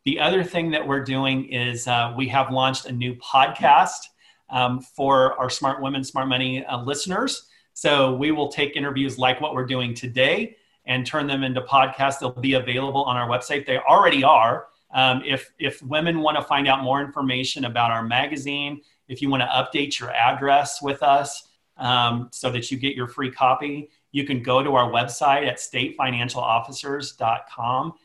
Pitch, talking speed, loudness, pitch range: 135 Hz, 180 wpm, -22 LUFS, 125-140 Hz